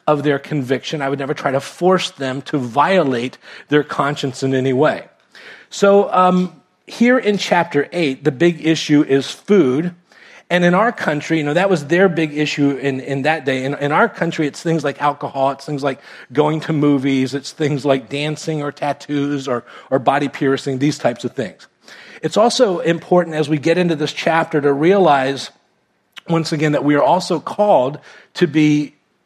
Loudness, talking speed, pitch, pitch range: -17 LUFS, 185 wpm, 150 Hz, 140-175 Hz